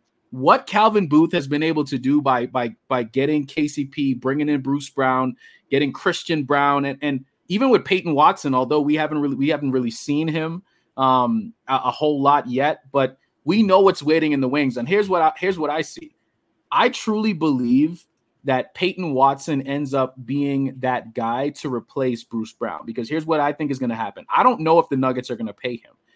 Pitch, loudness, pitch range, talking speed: 145 Hz, -20 LUFS, 130-160 Hz, 210 wpm